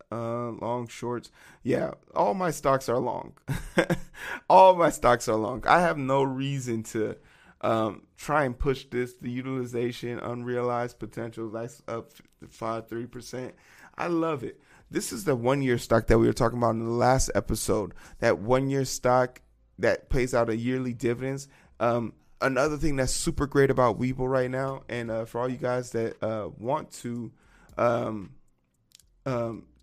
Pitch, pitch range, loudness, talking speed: 120 Hz, 115-130 Hz, -27 LUFS, 165 wpm